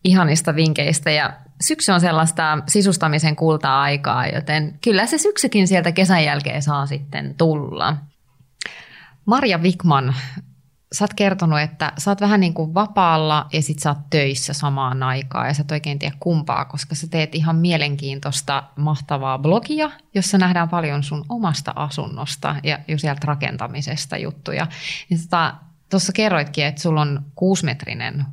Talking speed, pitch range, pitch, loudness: 145 wpm, 145-175 Hz, 155 Hz, -19 LUFS